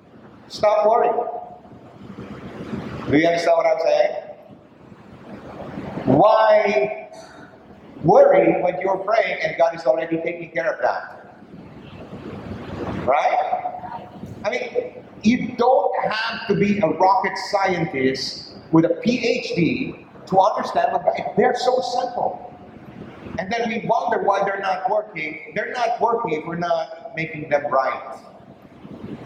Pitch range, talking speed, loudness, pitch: 165-235 Hz, 120 wpm, -20 LUFS, 210 Hz